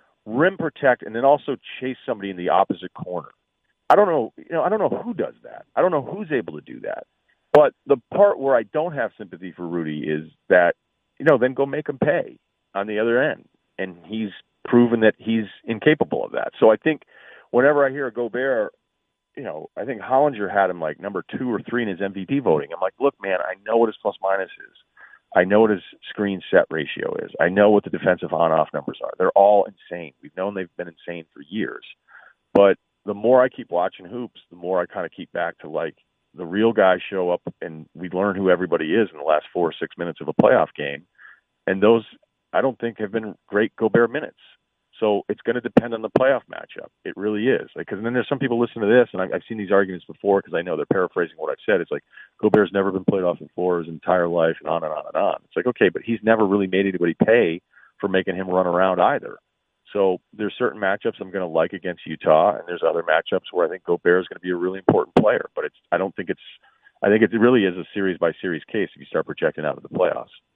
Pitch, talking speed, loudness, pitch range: 105 Hz, 245 wpm, -21 LUFS, 90-120 Hz